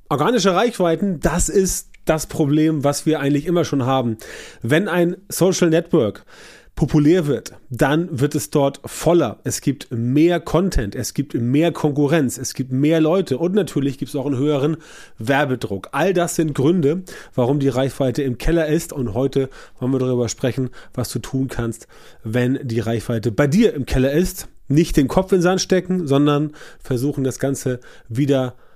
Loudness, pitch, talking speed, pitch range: -19 LUFS, 145 Hz, 170 wpm, 130-165 Hz